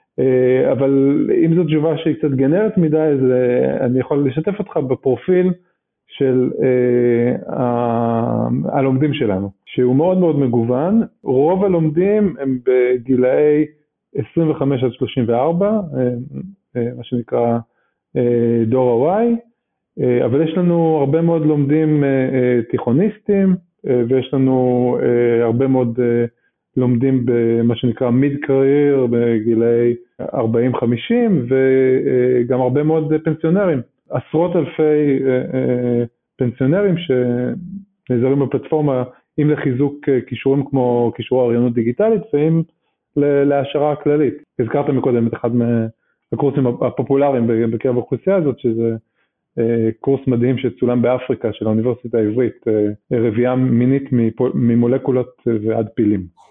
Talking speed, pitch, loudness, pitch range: 100 wpm, 130 Hz, -17 LUFS, 120-150 Hz